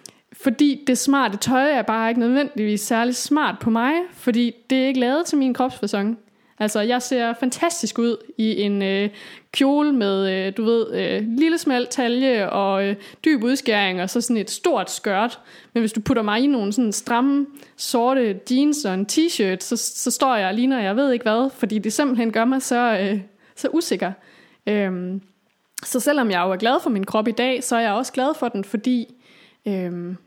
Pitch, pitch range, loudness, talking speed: 235 Hz, 210-260 Hz, -21 LUFS, 200 wpm